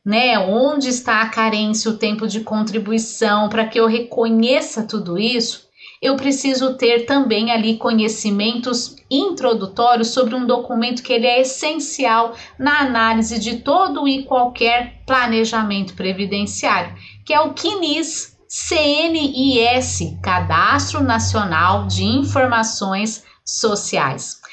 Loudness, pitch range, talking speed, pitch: -17 LUFS, 220-260 Hz, 115 wpm, 235 Hz